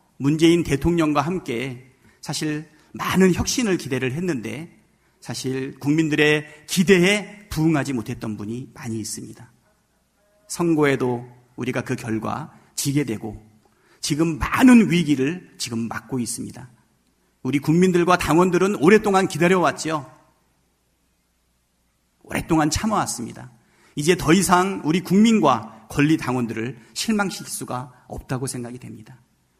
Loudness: -21 LUFS